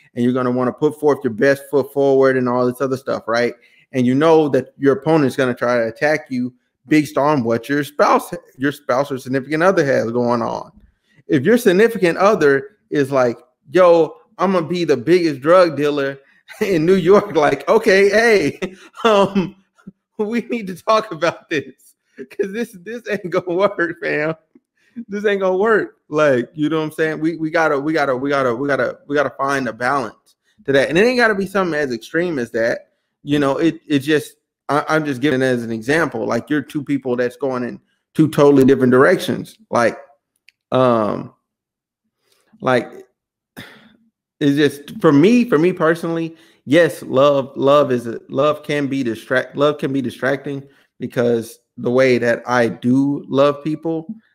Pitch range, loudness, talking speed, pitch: 135-180 Hz, -17 LUFS, 180 wpm, 150 Hz